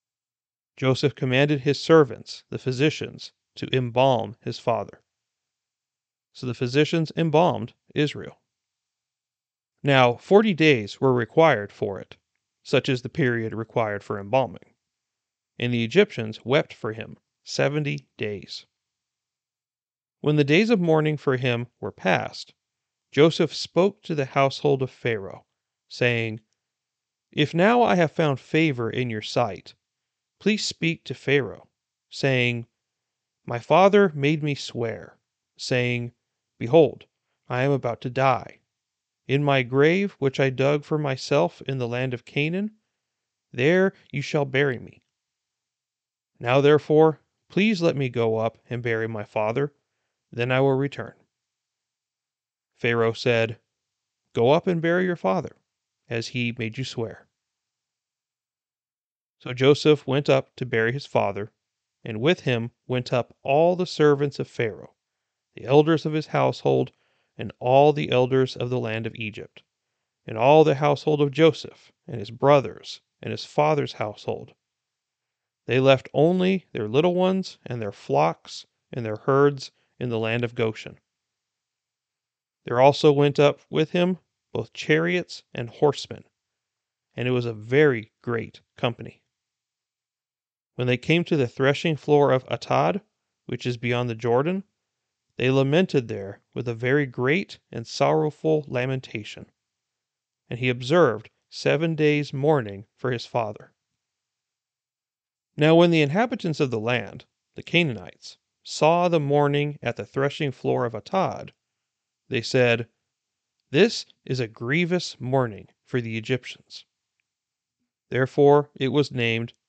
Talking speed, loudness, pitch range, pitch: 135 wpm, -23 LUFS, 120-150 Hz, 130 Hz